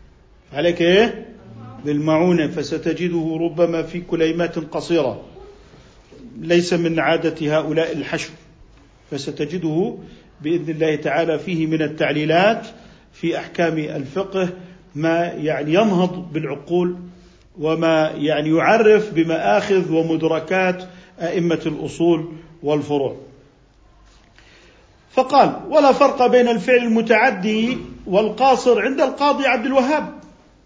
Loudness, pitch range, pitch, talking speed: -19 LUFS, 155-200 Hz, 170 Hz, 90 wpm